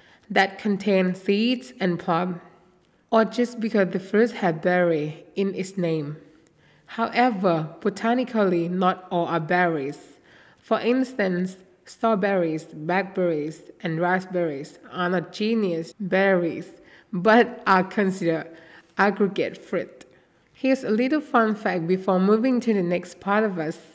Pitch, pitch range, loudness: 185 Hz, 170-215 Hz, -23 LUFS